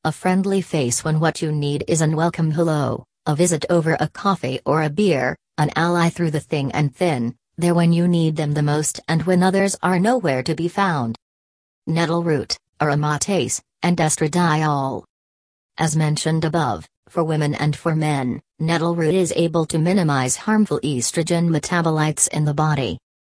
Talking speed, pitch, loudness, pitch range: 170 wpm, 160 Hz, -20 LUFS, 145-170 Hz